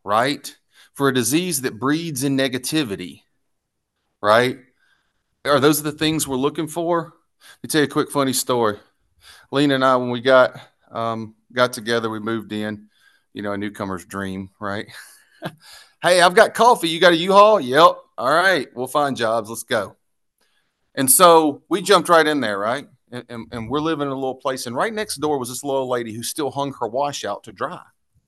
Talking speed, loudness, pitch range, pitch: 195 wpm, -19 LUFS, 115-150 Hz, 135 Hz